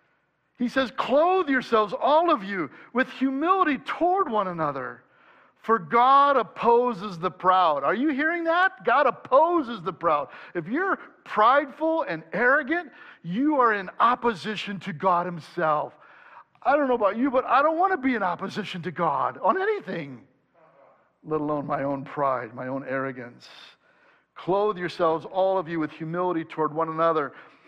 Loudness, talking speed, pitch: -24 LUFS, 155 wpm, 220 Hz